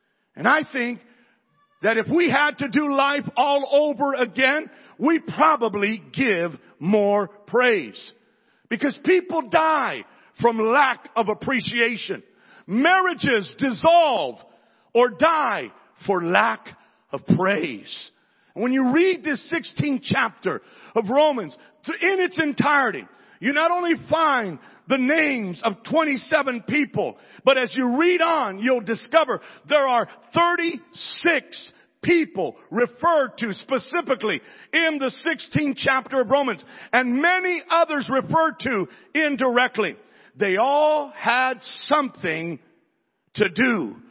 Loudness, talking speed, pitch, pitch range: -21 LUFS, 115 wpm, 270 Hz, 235-310 Hz